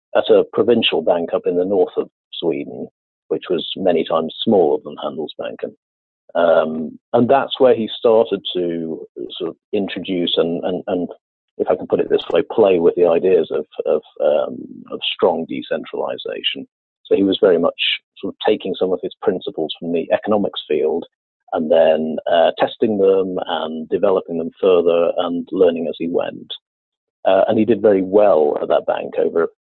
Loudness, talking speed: -18 LUFS, 175 wpm